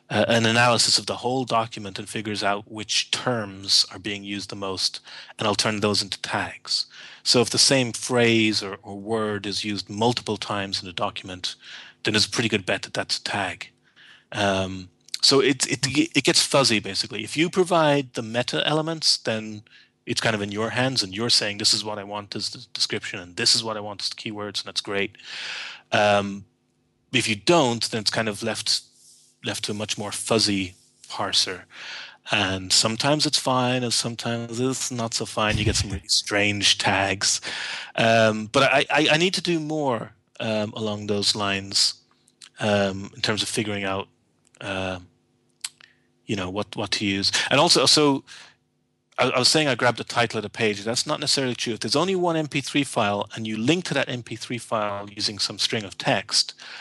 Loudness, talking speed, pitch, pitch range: -22 LUFS, 195 wpm, 110 Hz, 100-125 Hz